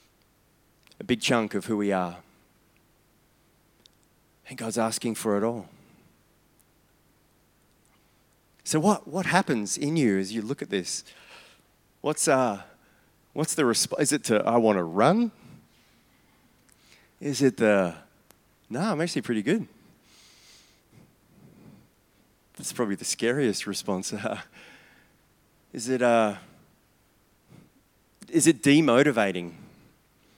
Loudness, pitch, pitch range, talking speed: -25 LUFS, 115 Hz, 105-145 Hz, 110 wpm